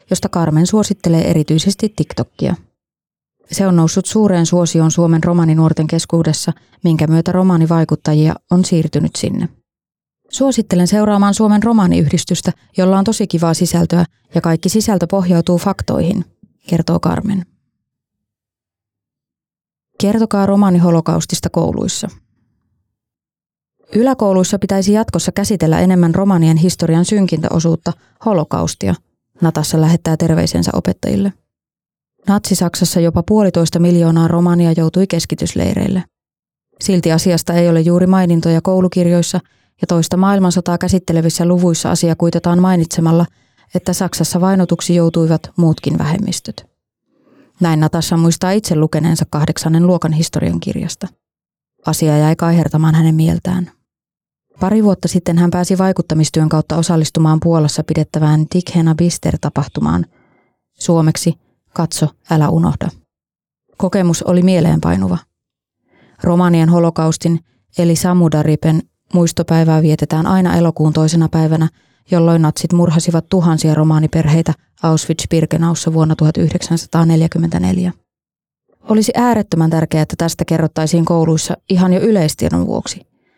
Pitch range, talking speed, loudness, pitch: 160-180 Hz, 100 wpm, -14 LUFS, 170 Hz